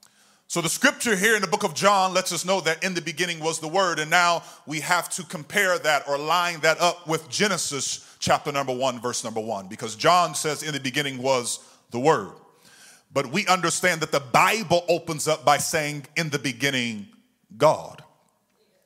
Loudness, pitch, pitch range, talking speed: -23 LUFS, 165 Hz, 145-185 Hz, 195 wpm